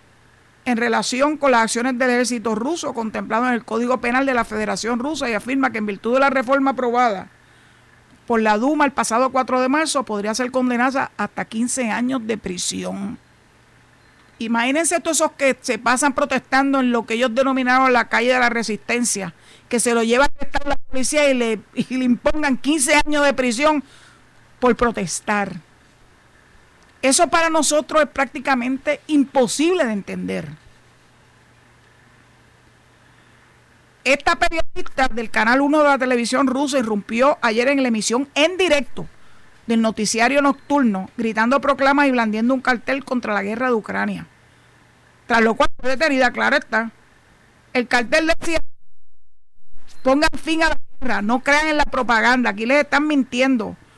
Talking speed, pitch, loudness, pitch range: 155 wpm, 255 Hz, -19 LUFS, 225-280 Hz